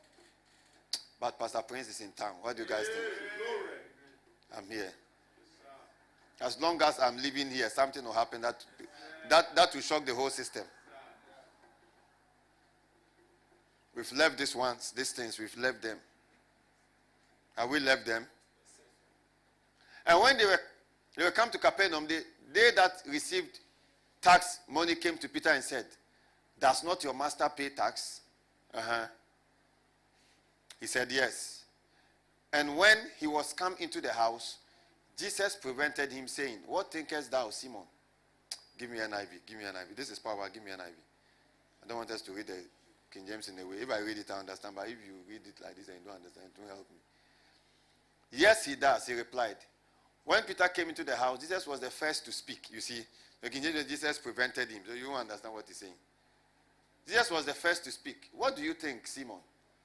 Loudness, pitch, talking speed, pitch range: -32 LUFS, 140 Hz, 180 wpm, 115-170 Hz